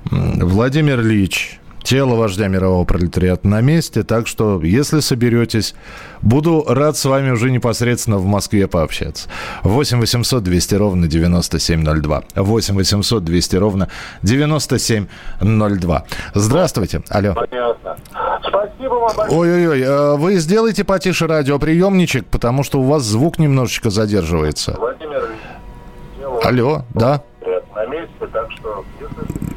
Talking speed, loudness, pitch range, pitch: 95 wpm, -16 LUFS, 95-145 Hz, 115 Hz